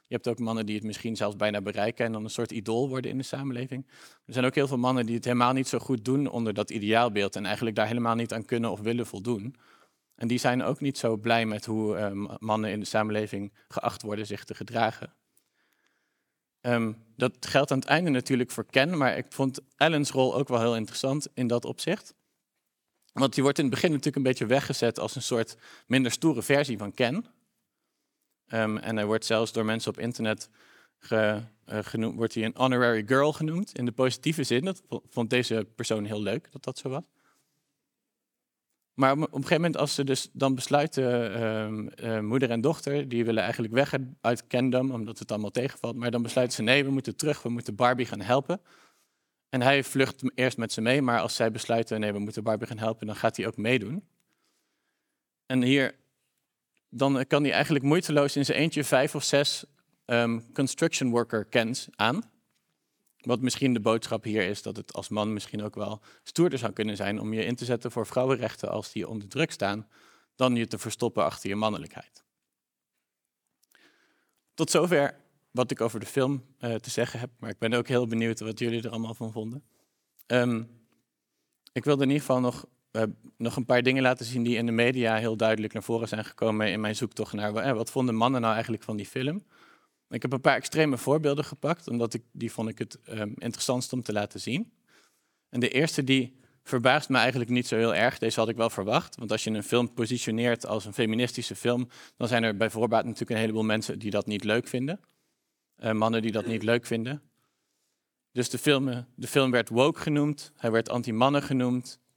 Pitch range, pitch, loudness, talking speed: 110-130 Hz, 120 Hz, -28 LUFS, 205 wpm